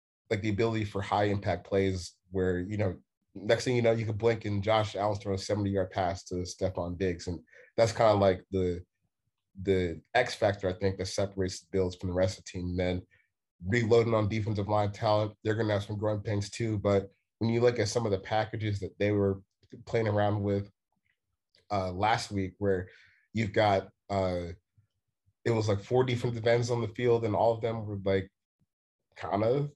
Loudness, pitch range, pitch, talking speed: -30 LUFS, 95-110 Hz, 100 Hz, 210 wpm